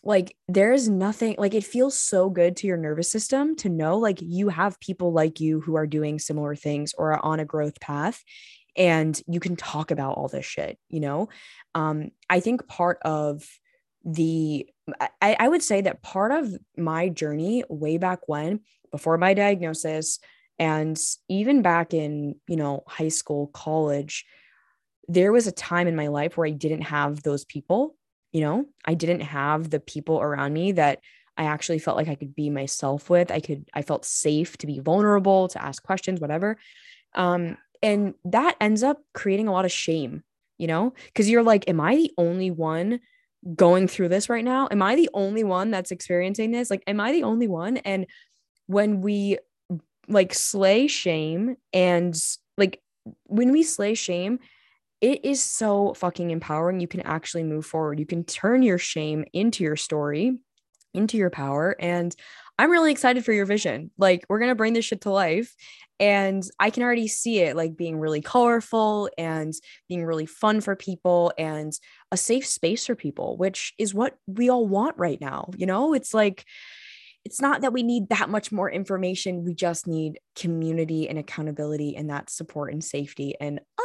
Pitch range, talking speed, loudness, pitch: 155-215 Hz, 185 wpm, -24 LUFS, 180 Hz